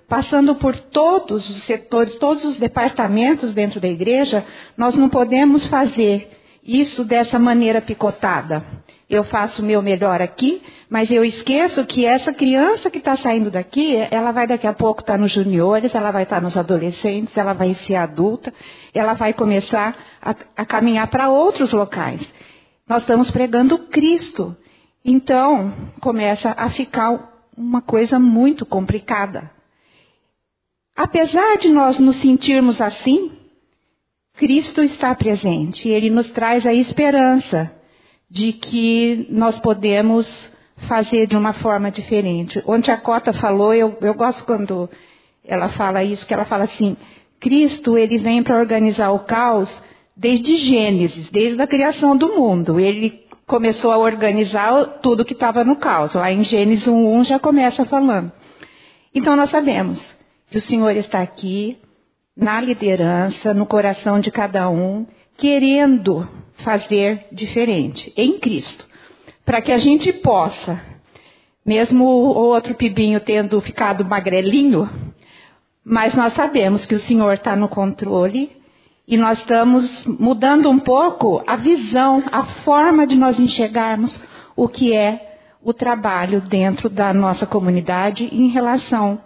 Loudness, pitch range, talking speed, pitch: -17 LUFS, 210-260 Hz, 140 wpm, 230 Hz